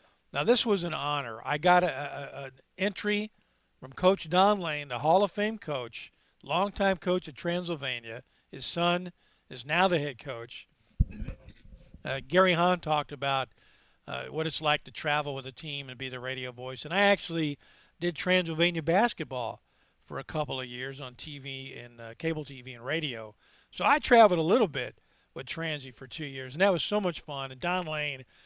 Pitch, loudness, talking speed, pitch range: 150 Hz, -29 LUFS, 190 wpm, 135-180 Hz